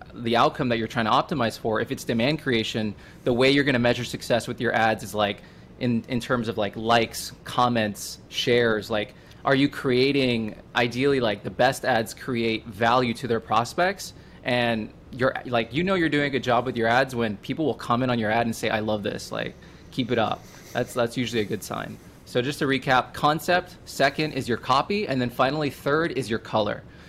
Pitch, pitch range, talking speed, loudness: 120 Hz, 115-135 Hz, 215 wpm, -24 LUFS